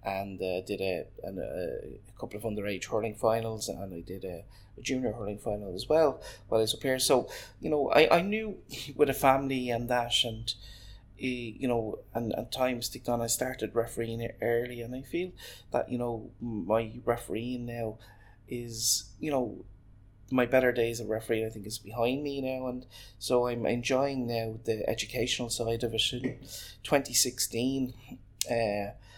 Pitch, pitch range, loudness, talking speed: 115 Hz, 105-125 Hz, -31 LUFS, 175 wpm